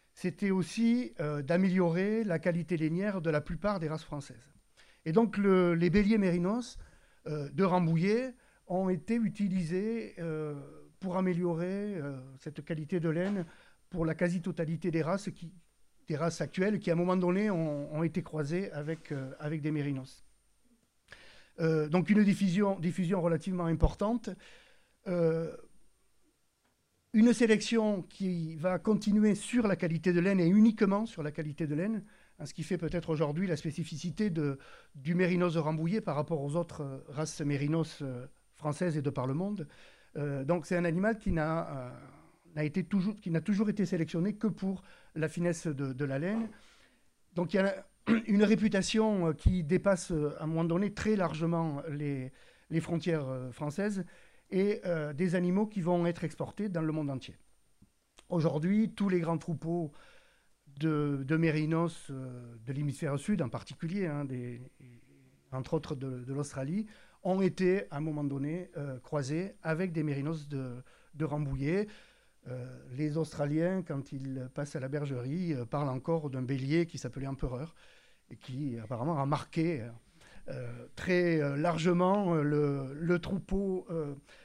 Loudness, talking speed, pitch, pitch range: -32 LUFS, 160 wpm, 165 Hz, 150-185 Hz